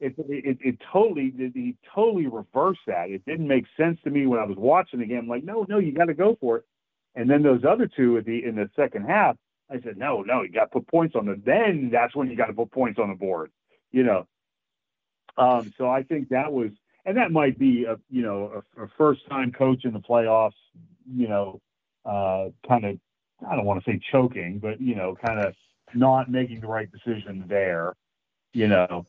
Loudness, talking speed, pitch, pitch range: -24 LUFS, 225 wpm, 125 Hz, 110-145 Hz